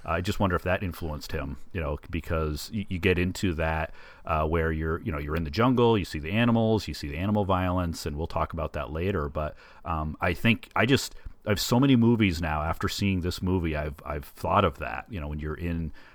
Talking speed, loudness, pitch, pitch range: 240 wpm, -28 LUFS, 85 Hz, 80-100 Hz